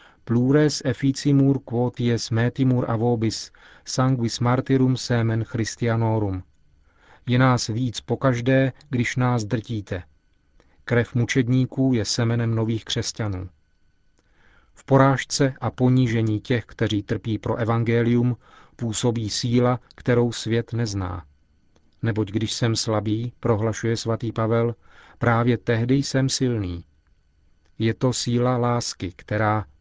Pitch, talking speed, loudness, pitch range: 115 Hz, 105 wpm, -23 LUFS, 105-125 Hz